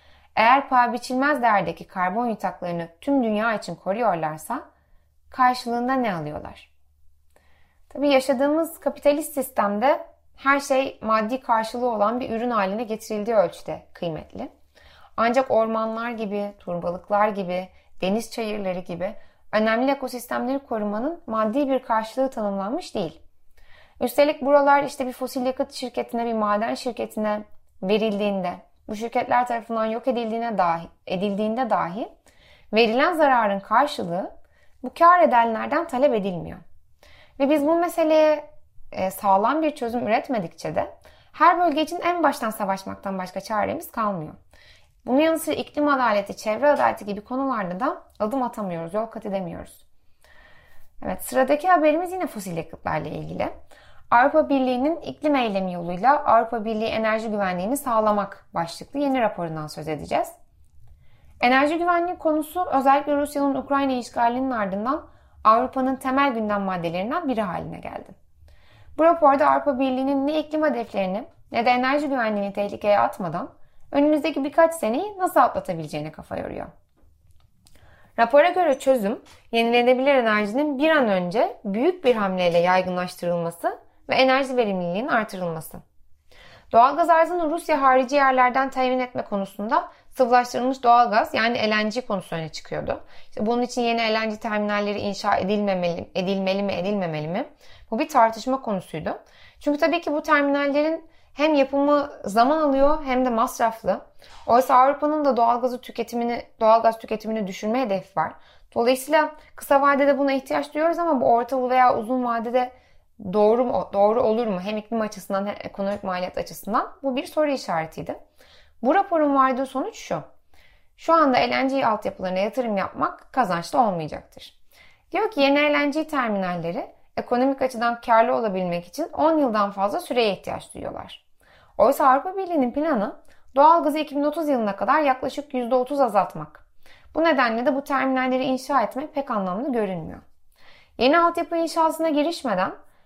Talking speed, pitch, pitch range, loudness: 130 wpm, 245 Hz, 205-280 Hz, -22 LUFS